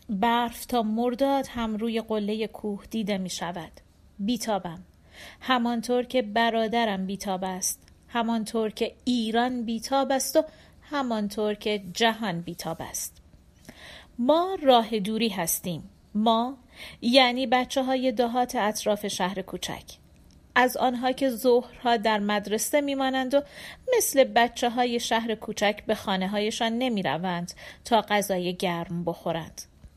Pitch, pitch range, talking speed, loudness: 225 Hz, 195-245 Hz, 120 wpm, -26 LUFS